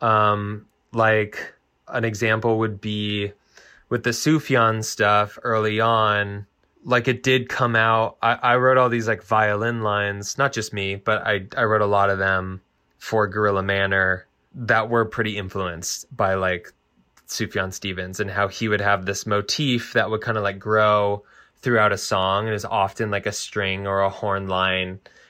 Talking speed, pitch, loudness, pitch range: 175 wpm, 105 Hz, -21 LUFS, 100-115 Hz